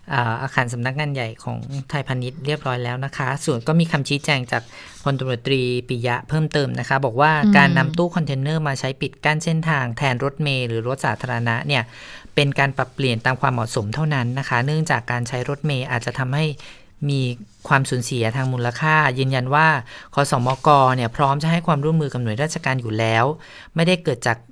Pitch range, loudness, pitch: 125-150 Hz, -20 LUFS, 135 Hz